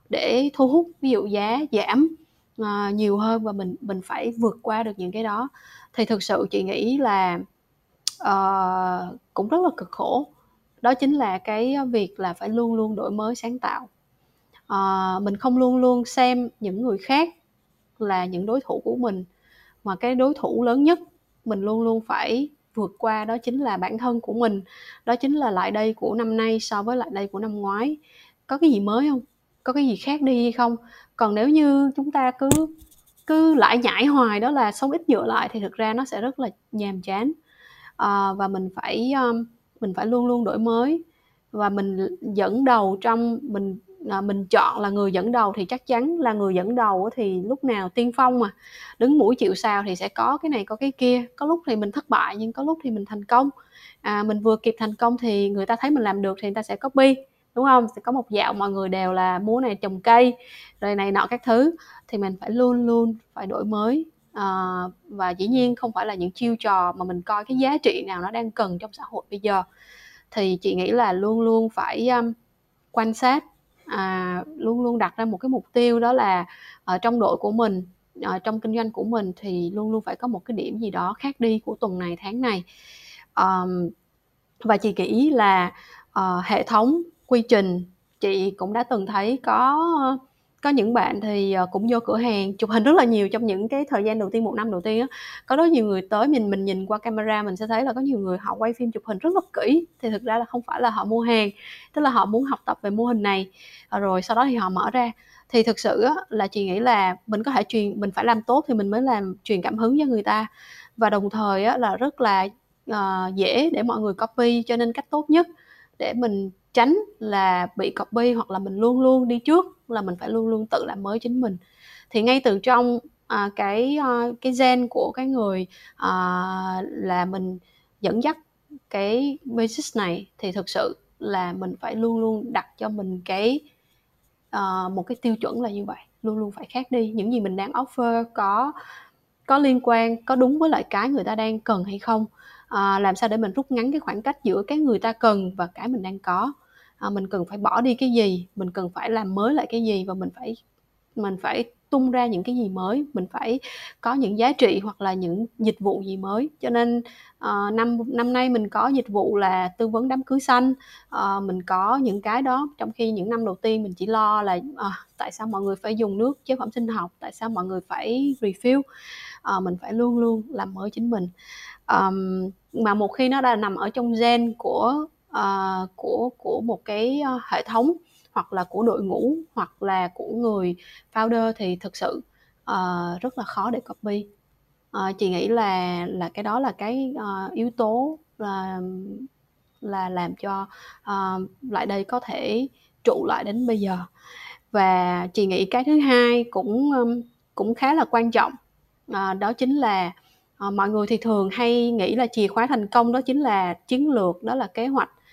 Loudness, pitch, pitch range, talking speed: -23 LUFS, 225 Hz, 195-250 Hz, 220 wpm